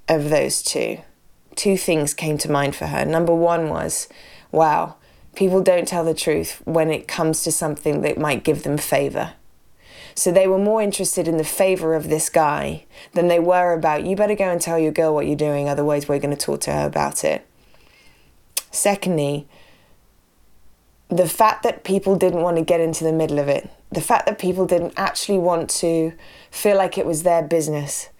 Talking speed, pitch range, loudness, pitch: 195 wpm, 155-185 Hz, -20 LUFS, 165 Hz